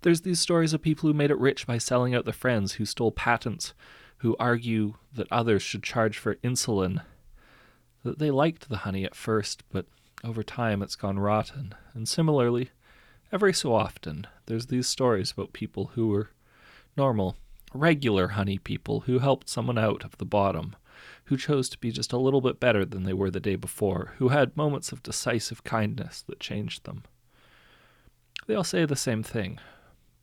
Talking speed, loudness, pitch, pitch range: 180 wpm, -27 LUFS, 115 Hz, 100-130 Hz